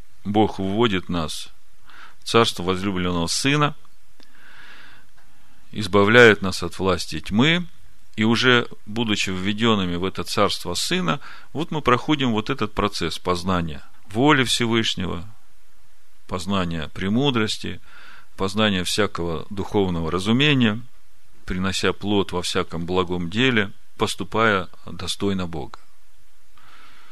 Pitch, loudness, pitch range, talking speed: 100 Hz, -21 LUFS, 90-115 Hz, 95 wpm